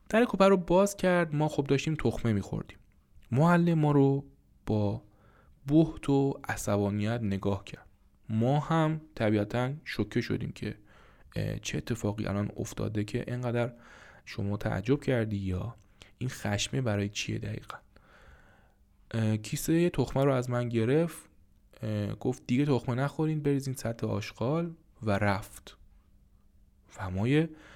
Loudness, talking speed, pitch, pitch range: -30 LUFS, 120 wpm, 120 Hz, 105-145 Hz